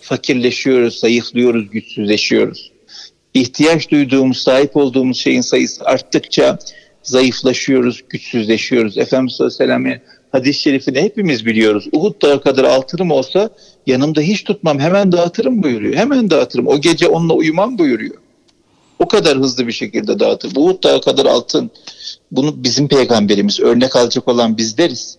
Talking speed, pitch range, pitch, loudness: 130 wpm, 120-170 Hz, 135 Hz, -14 LUFS